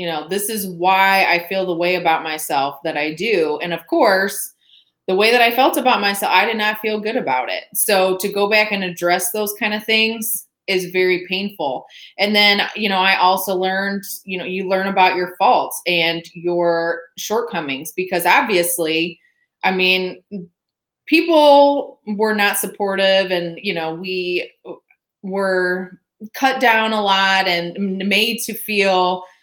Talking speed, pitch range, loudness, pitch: 165 wpm, 180-215 Hz, -17 LUFS, 195 Hz